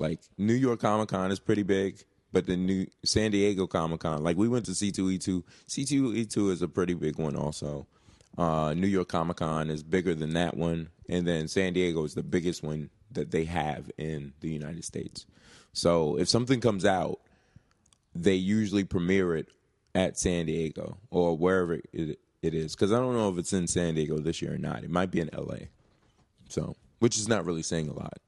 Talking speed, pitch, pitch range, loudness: 195 wpm, 90 Hz, 80-100 Hz, -29 LUFS